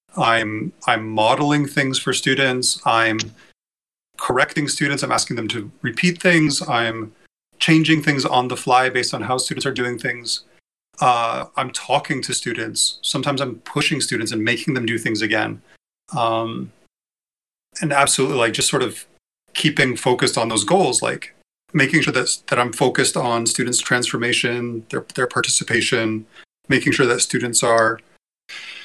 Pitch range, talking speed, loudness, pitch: 115-140 Hz, 150 wpm, -19 LUFS, 125 Hz